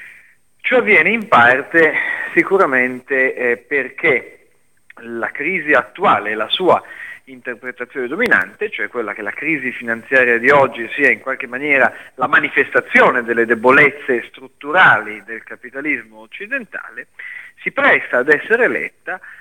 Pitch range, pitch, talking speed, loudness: 120-170 Hz, 130 Hz, 120 wpm, -15 LUFS